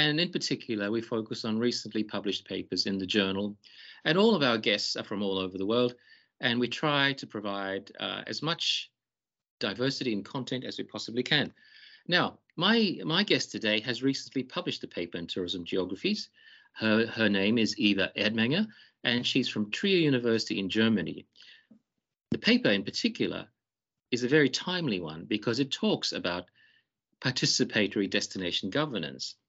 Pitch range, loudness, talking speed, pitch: 105-140 Hz, -29 LUFS, 165 wpm, 120 Hz